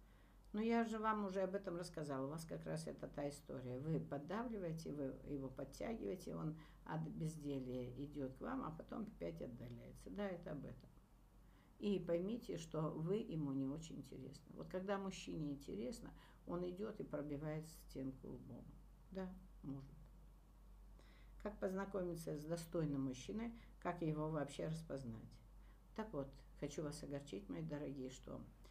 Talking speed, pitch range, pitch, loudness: 150 wpm, 135-185 Hz, 155 Hz, -47 LUFS